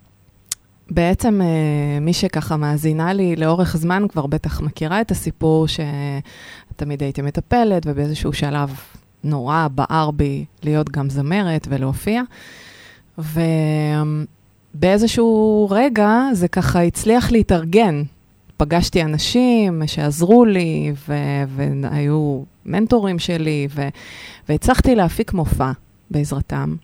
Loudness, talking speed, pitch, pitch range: -18 LUFS, 90 wpm, 155 Hz, 145-185 Hz